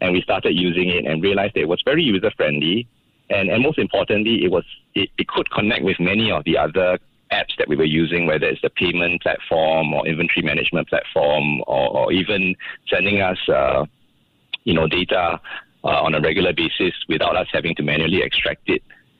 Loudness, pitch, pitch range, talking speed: -19 LUFS, 90 Hz, 80-95 Hz, 195 wpm